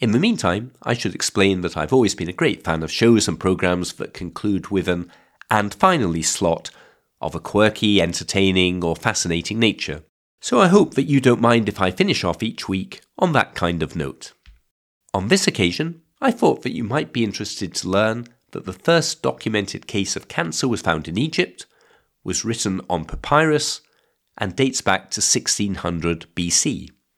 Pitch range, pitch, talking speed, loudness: 85-115 Hz, 100 Hz, 180 wpm, -20 LUFS